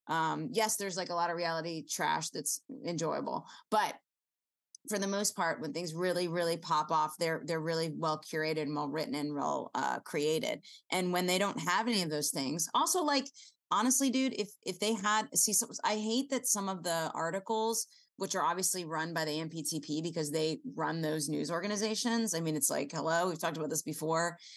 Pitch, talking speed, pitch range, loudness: 170 Hz, 205 wpm, 160-210 Hz, -33 LUFS